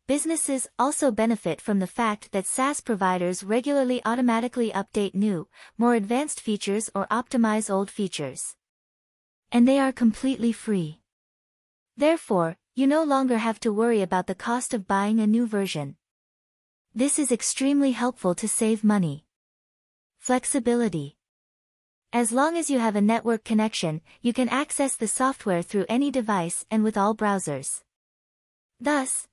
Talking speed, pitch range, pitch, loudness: 140 wpm, 195-255 Hz, 225 Hz, -25 LUFS